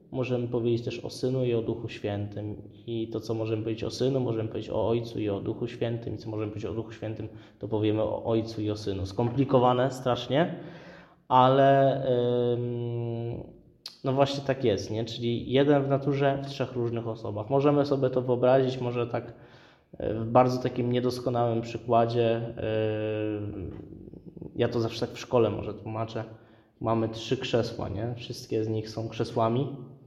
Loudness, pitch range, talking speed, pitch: -28 LUFS, 110-130 Hz, 170 wpm, 120 Hz